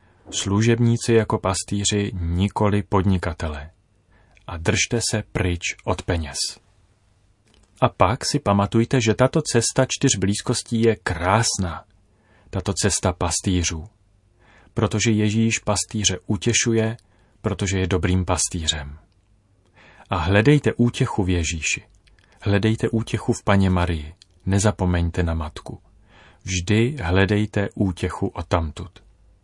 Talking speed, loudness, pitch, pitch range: 105 wpm, -21 LUFS, 100 Hz, 90-110 Hz